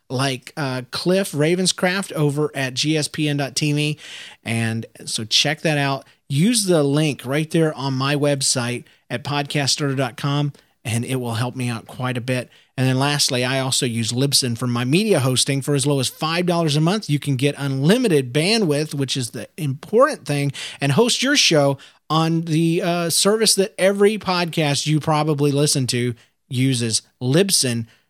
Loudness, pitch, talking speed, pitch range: -19 LUFS, 145 Hz, 160 wpm, 130-160 Hz